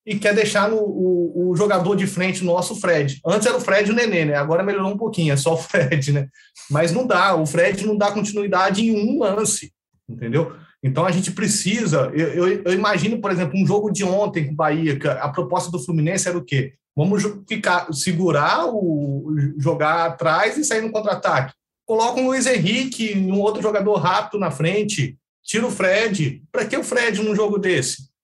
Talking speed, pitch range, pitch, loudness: 205 wpm, 160-210 Hz, 185 Hz, -20 LUFS